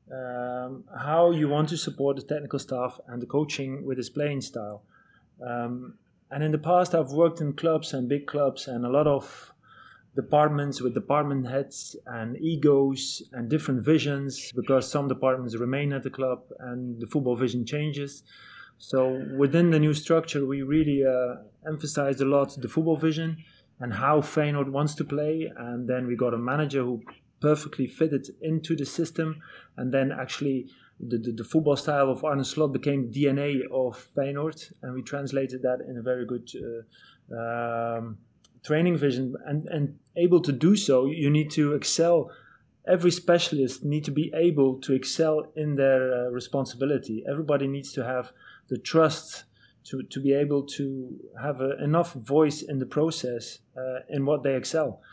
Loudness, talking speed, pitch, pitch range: -27 LUFS, 170 wpm, 140 Hz, 125-150 Hz